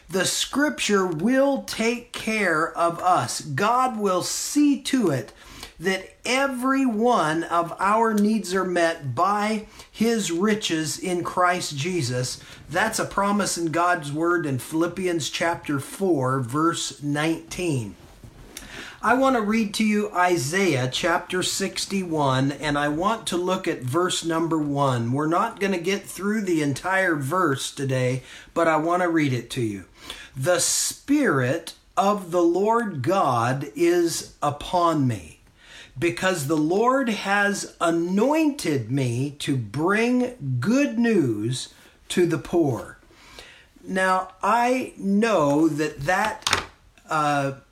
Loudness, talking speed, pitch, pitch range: -23 LUFS, 130 wpm, 175 Hz, 145-205 Hz